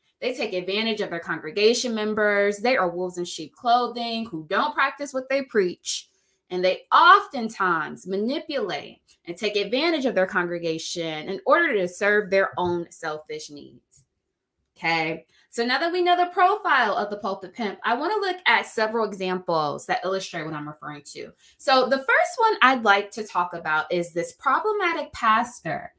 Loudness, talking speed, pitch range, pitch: -23 LUFS, 175 wpm, 175-255 Hz, 205 Hz